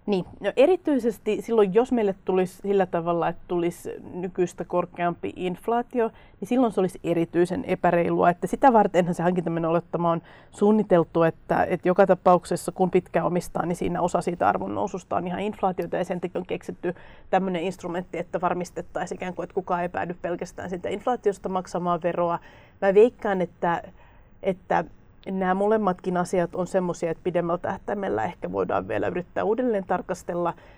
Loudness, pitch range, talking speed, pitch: -25 LUFS, 175-200 Hz, 160 wpm, 185 Hz